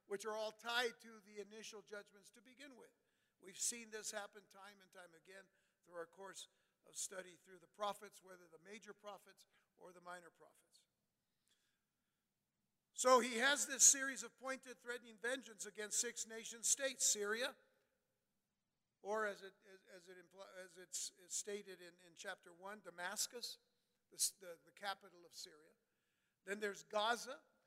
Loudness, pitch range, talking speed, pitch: -40 LUFS, 185-235 Hz, 155 wpm, 205 Hz